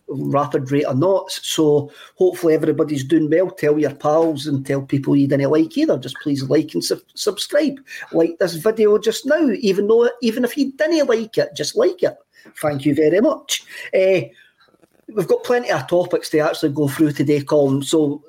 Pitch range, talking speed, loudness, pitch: 150-225 Hz, 190 wpm, -18 LUFS, 160 Hz